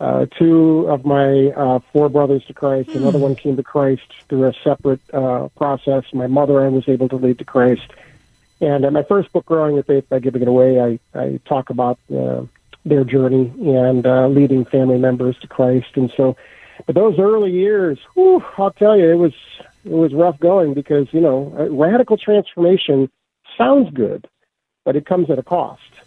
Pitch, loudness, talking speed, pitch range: 140 Hz, -16 LUFS, 195 wpm, 130-160 Hz